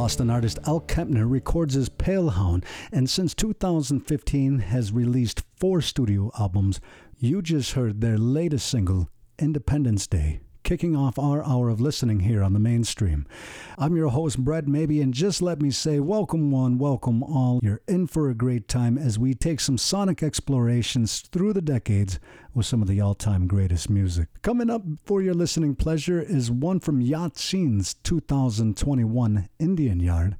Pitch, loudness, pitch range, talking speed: 130 Hz, -24 LUFS, 110-155 Hz, 165 wpm